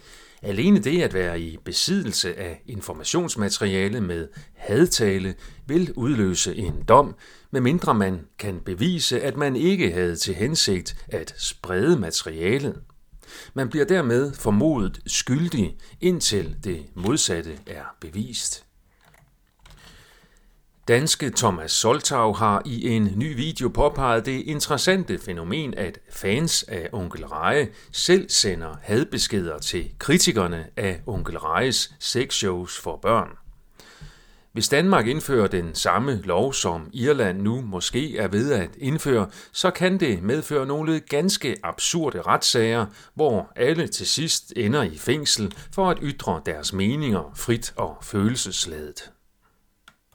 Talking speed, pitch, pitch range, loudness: 120 wpm, 120 Hz, 95-155 Hz, -23 LUFS